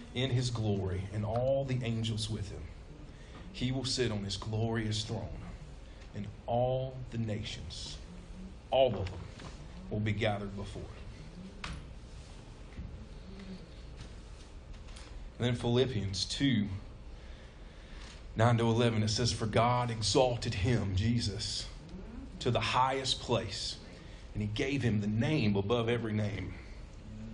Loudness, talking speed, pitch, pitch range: -33 LUFS, 120 wpm, 105 Hz, 95-120 Hz